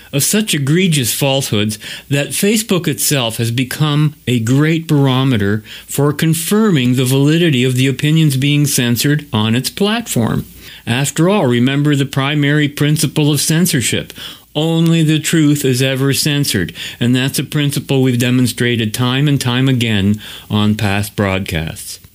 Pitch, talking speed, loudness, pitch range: 140 Hz, 140 wpm, -14 LUFS, 120-150 Hz